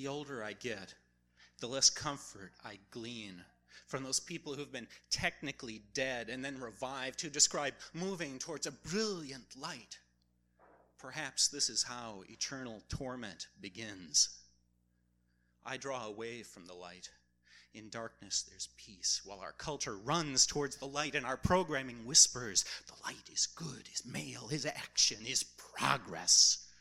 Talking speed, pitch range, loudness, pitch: 145 wpm, 90-140 Hz, -34 LUFS, 120 Hz